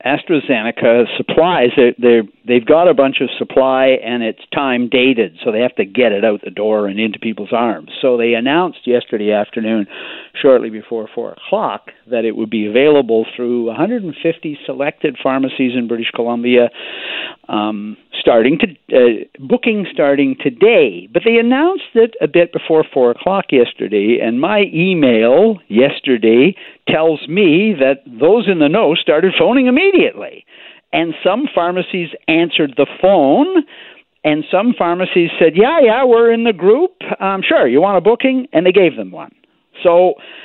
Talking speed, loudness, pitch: 160 wpm, -13 LUFS, 155 Hz